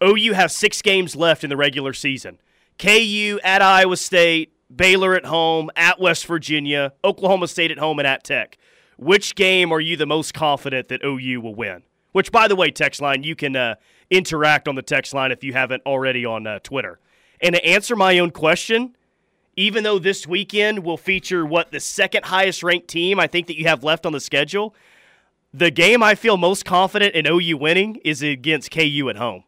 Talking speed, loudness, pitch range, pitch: 200 wpm, -18 LUFS, 145-190 Hz, 170 Hz